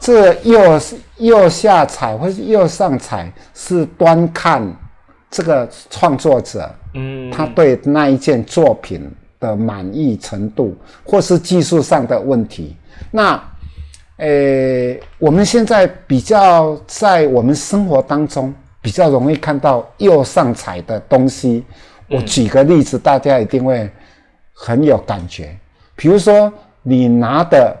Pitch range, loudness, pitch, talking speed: 110-170 Hz, -13 LUFS, 135 Hz, 185 characters per minute